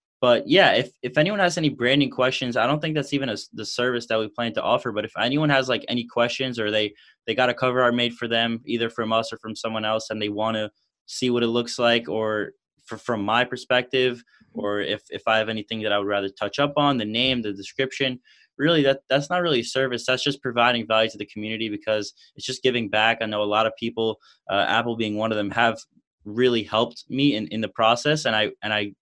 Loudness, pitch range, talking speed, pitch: -23 LUFS, 110-130 Hz, 250 wpm, 115 Hz